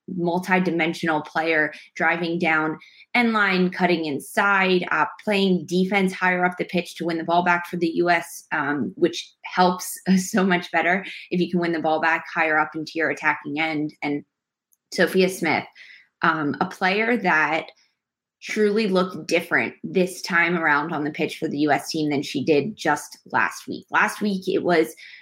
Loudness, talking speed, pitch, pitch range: -22 LUFS, 170 wpm, 175 Hz, 160-185 Hz